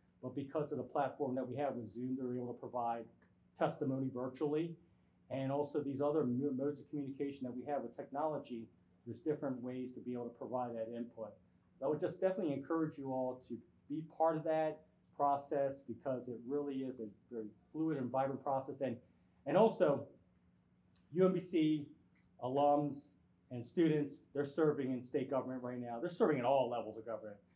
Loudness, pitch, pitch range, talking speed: -39 LUFS, 135 Hz, 120-145 Hz, 185 wpm